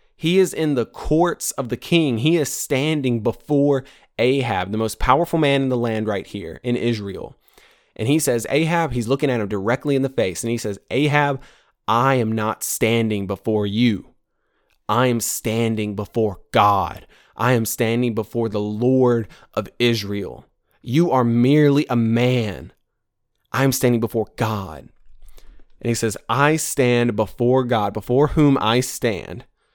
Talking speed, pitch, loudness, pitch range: 160 wpm, 120 Hz, -20 LUFS, 110-135 Hz